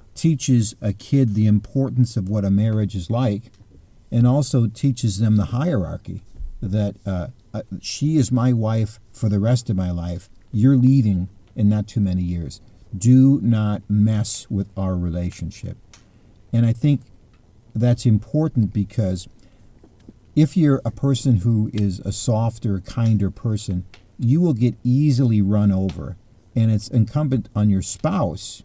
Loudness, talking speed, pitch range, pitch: -20 LUFS, 145 wpm, 100-125 Hz, 110 Hz